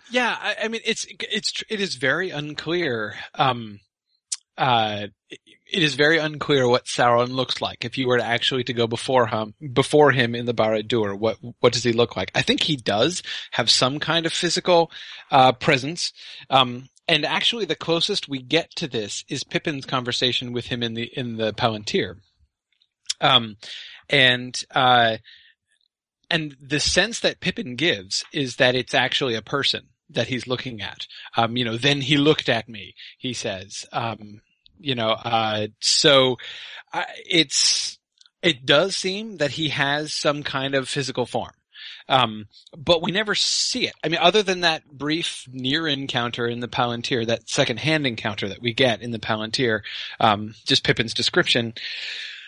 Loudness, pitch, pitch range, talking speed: -21 LUFS, 130 Hz, 120-155 Hz, 170 wpm